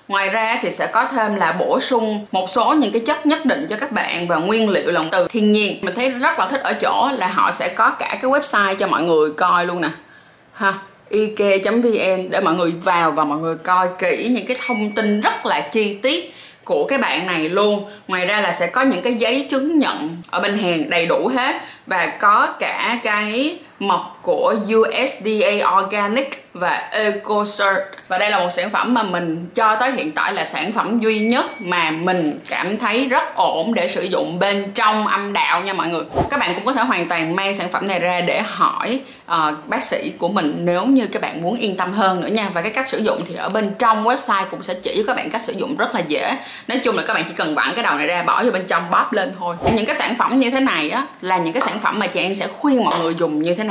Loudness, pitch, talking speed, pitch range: -18 LUFS, 205 Hz, 250 wpm, 180-235 Hz